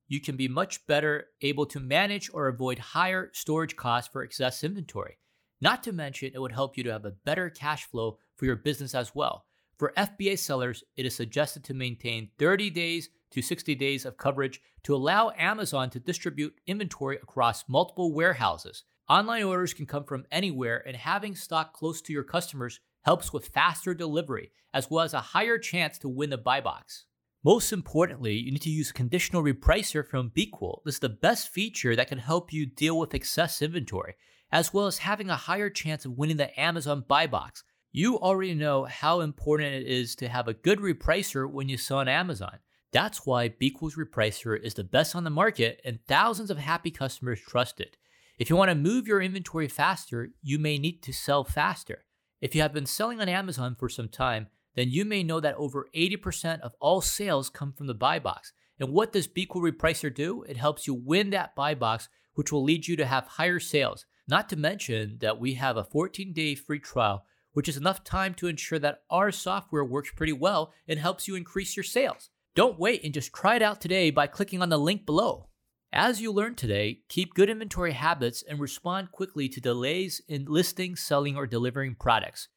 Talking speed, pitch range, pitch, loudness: 200 wpm, 130-180 Hz, 150 Hz, -28 LUFS